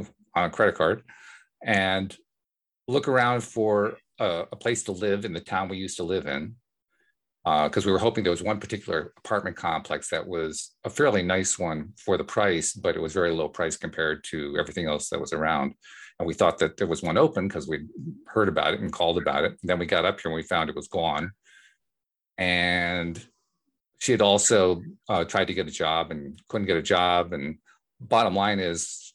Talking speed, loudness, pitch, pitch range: 210 wpm, -26 LUFS, 95 Hz, 90-110 Hz